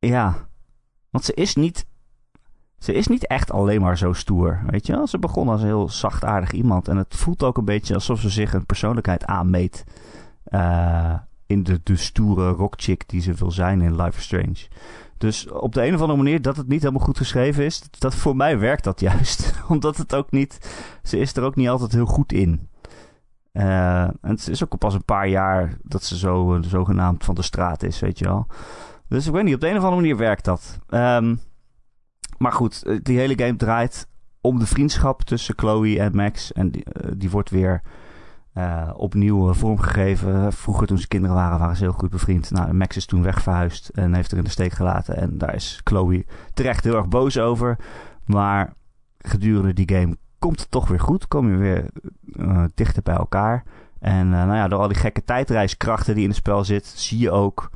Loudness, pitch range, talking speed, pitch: -21 LUFS, 90-120 Hz, 210 wpm, 100 Hz